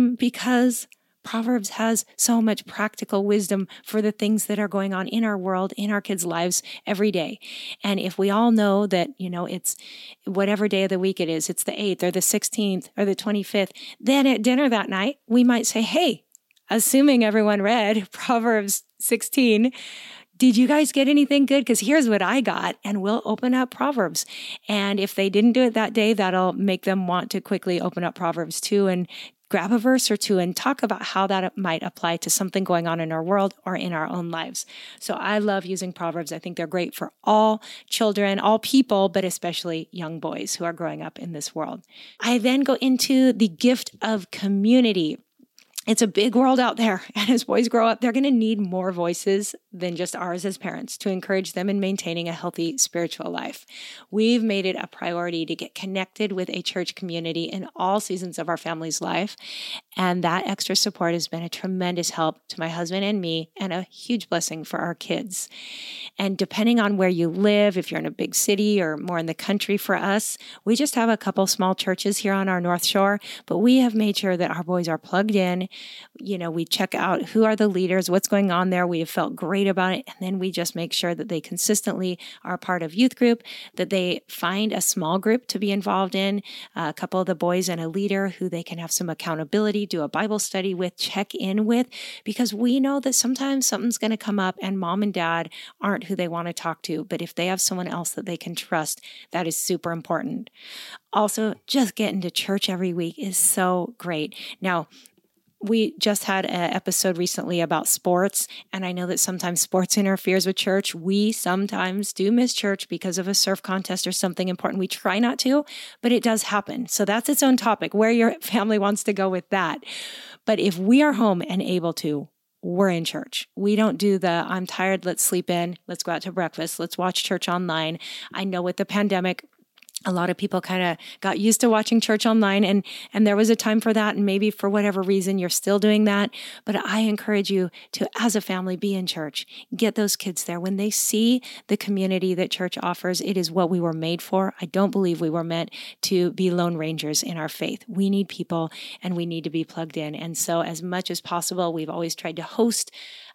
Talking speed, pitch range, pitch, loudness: 215 wpm, 180-220 Hz, 195 Hz, -23 LUFS